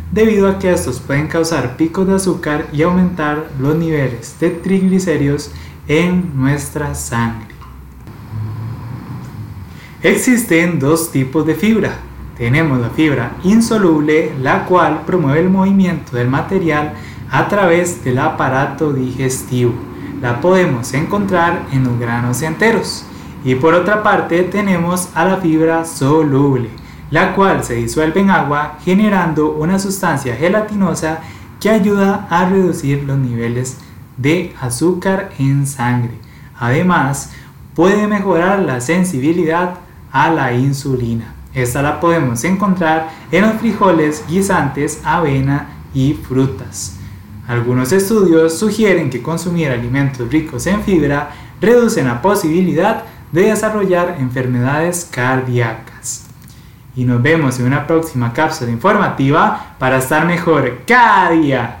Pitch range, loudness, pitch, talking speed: 130-175 Hz, -14 LUFS, 155 Hz, 120 wpm